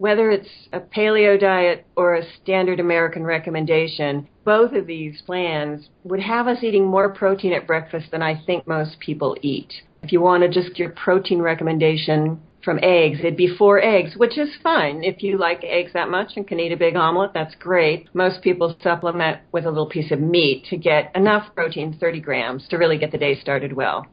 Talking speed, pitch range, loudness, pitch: 200 wpm, 160-190 Hz, -19 LUFS, 170 Hz